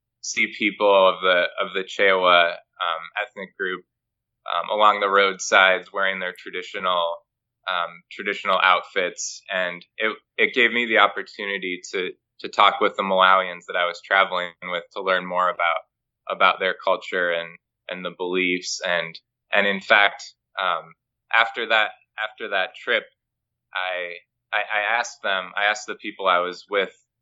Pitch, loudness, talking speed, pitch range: 95 Hz, -21 LUFS, 155 wpm, 90-100 Hz